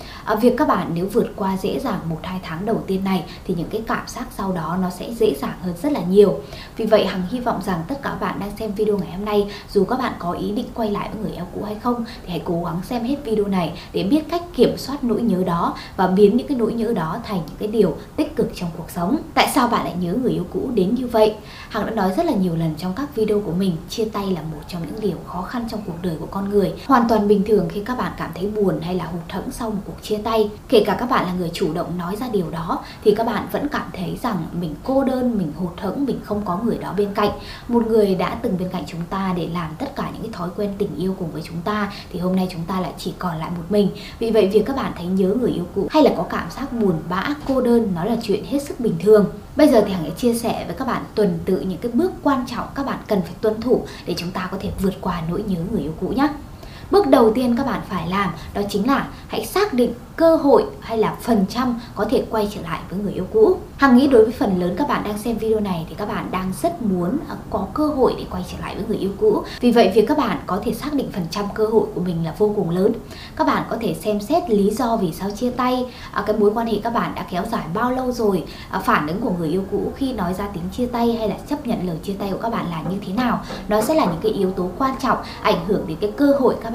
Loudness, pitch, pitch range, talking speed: -21 LUFS, 210 Hz, 185-230 Hz, 290 wpm